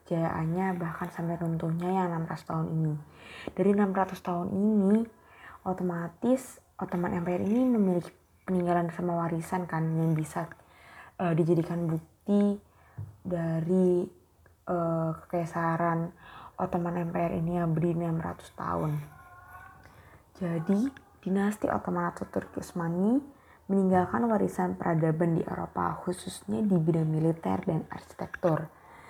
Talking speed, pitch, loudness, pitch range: 110 wpm, 175 Hz, -30 LUFS, 165-190 Hz